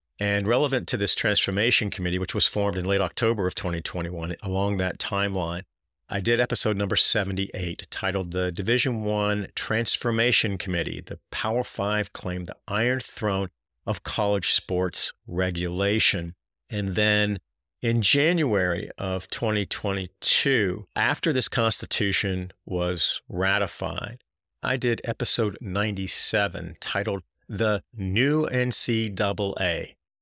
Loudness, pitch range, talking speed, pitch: -24 LUFS, 90-110 Hz, 115 wpm, 100 Hz